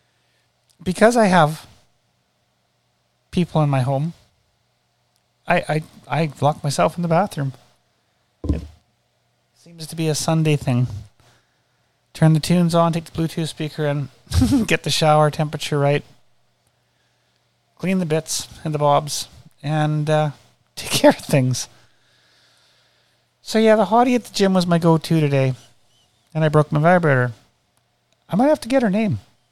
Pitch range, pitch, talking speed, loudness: 120-165 Hz, 150 Hz, 145 wpm, -19 LUFS